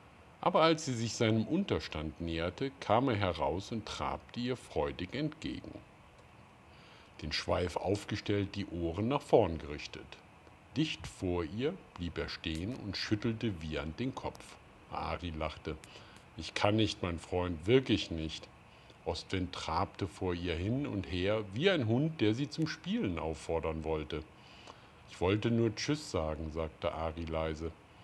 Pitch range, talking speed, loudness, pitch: 80-115 Hz, 145 wpm, -35 LUFS, 95 Hz